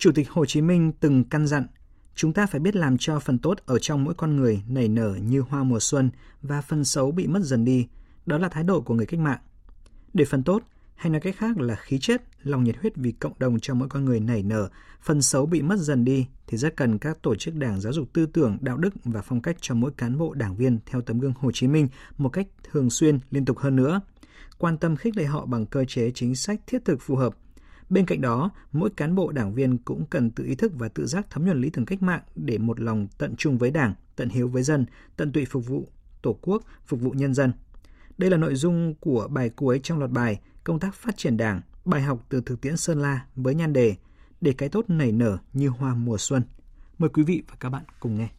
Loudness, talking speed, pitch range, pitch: -25 LUFS, 255 wpm, 120-160 Hz, 135 Hz